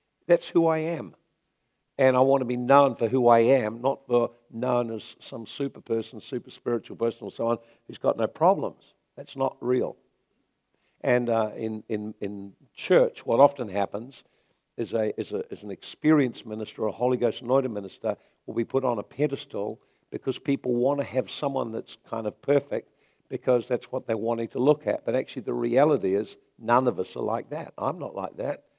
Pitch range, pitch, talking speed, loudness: 110-135 Hz, 120 Hz, 200 wpm, -26 LUFS